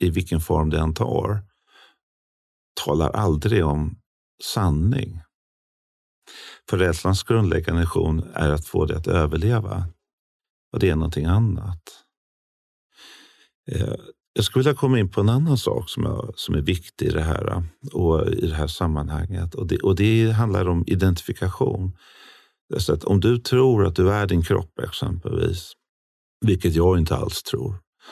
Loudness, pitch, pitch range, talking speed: -22 LUFS, 95 Hz, 85-110 Hz, 145 wpm